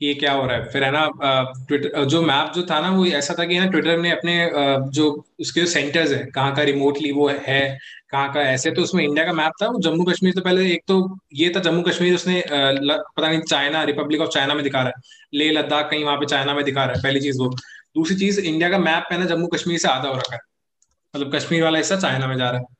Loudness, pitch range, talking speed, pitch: -20 LUFS, 140-170 Hz, 265 wpm, 150 Hz